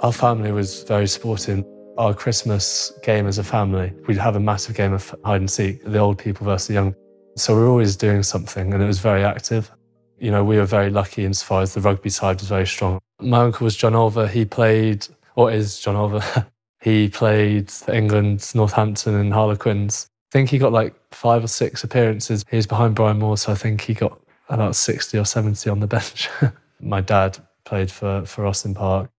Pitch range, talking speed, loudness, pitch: 100-115 Hz, 210 wpm, -20 LUFS, 105 Hz